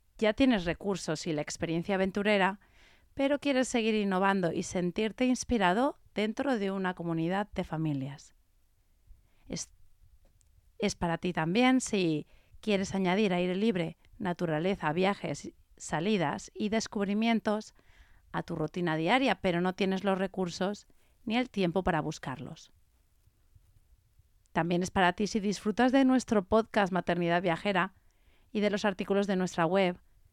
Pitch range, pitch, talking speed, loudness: 155-210 Hz, 185 Hz, 135 wpm, -30 LUFS